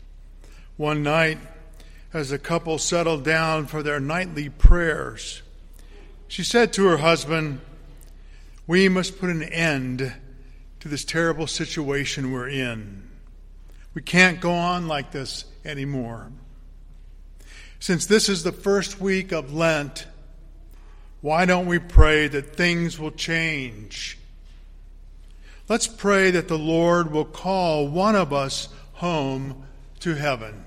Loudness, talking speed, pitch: -22 LUFS, 125 wpm, 150 Hz